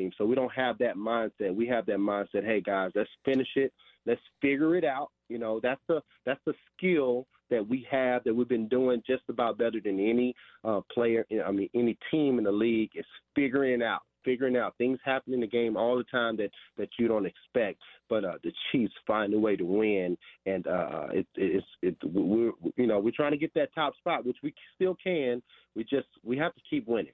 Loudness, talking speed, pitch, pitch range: -30 LUFS, 220 wpm, 120 Hz, 110-130 Hz